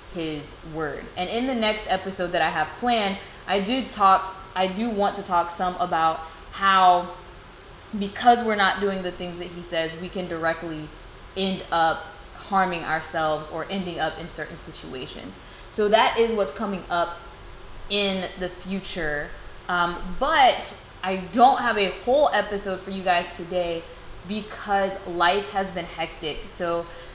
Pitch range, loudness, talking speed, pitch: 165-195 Hz, -24 LUFS, 155 wpm, 180 Hz